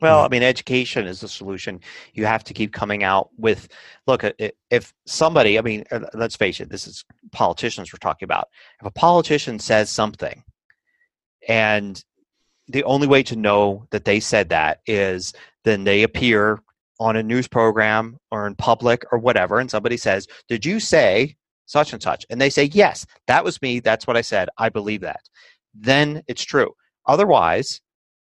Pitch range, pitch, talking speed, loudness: 105-135 Hz, 115 Hz, 175 wpm, -19 LUFS